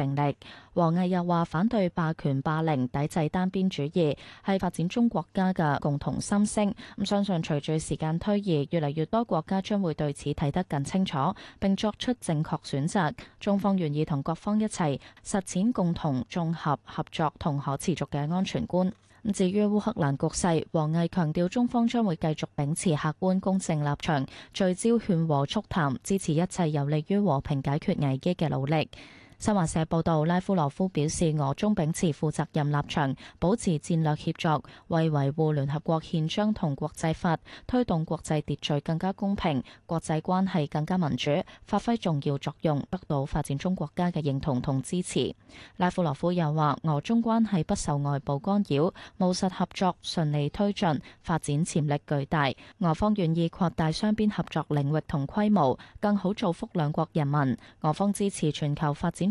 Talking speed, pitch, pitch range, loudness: 270 characters per minute, 165 Hz, 150-190 Hz, -28 LUFS